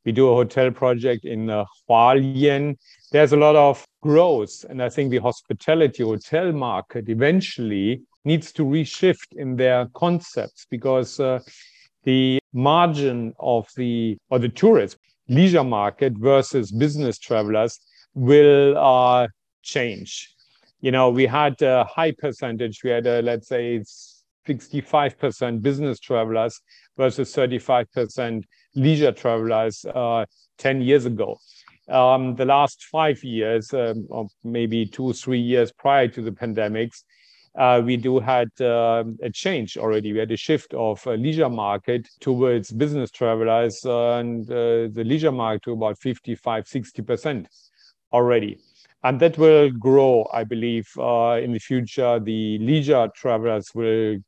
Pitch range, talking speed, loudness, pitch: 115-140 Hz, 145 wpm, -21 LUFS, 125 Hz